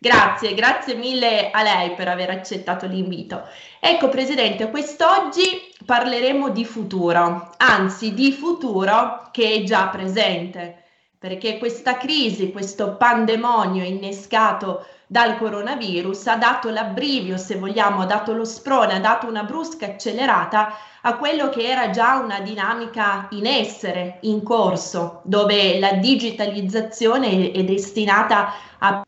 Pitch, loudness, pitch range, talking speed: 215 Hz, -19 LUFS, 195-240 Hz, 125 wpm